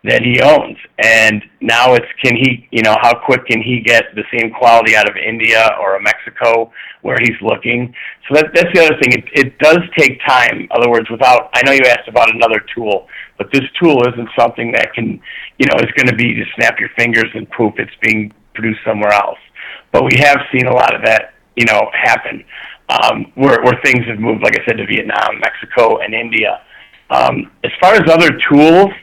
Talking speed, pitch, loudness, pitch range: 215 wpm, 120 Hz, -11 LUFS, 110-135 Hz